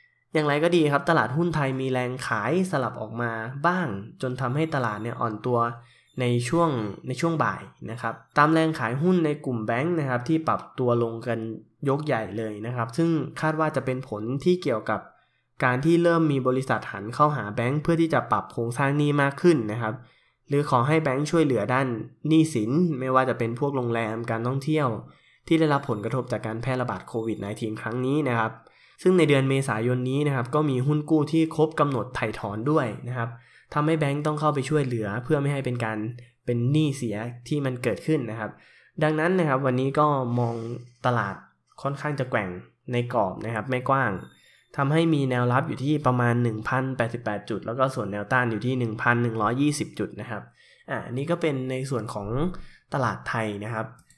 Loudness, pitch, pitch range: -25 LUFS, 130 Hz, 115-150 Hz